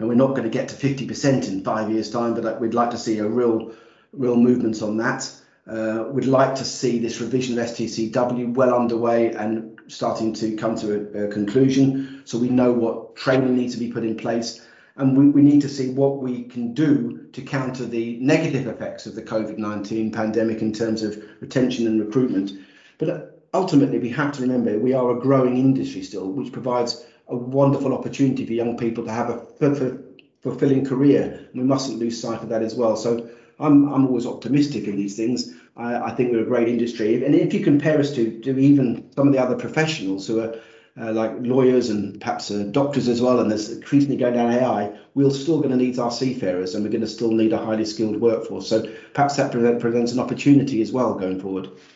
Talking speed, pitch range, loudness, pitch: 215 wpm, 110-130 Hz, -21 LUFS, 120 Hz